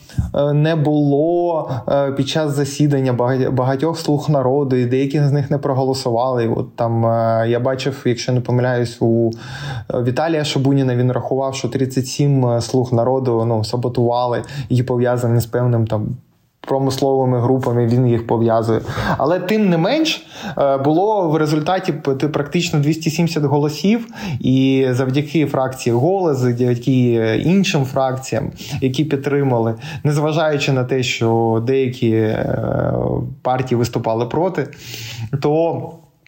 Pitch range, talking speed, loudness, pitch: 120-150 Hz, 115 wpm, -17 LUFS, 135 Hz